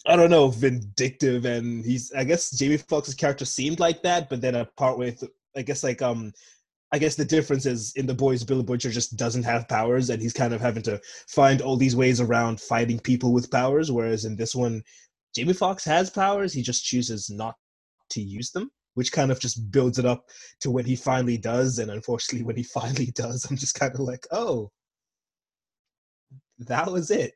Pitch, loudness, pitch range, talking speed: 125 Hz, -25 LUFS, 120-140 Hz, 205 wpm